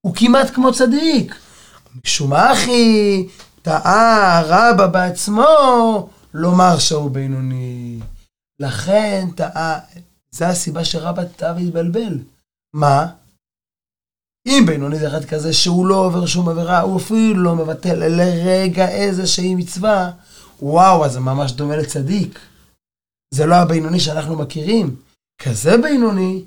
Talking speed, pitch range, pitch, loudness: 115 wpm, 155-195 Hz, 175 Hz, -15 LUFS